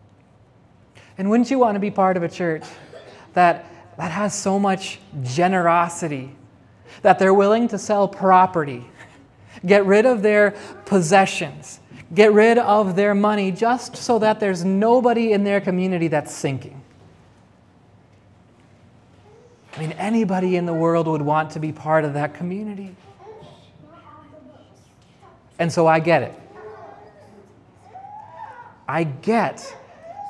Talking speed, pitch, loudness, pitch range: 125 wpm, 185 Hz, -19 LUFS, 160-210 Hz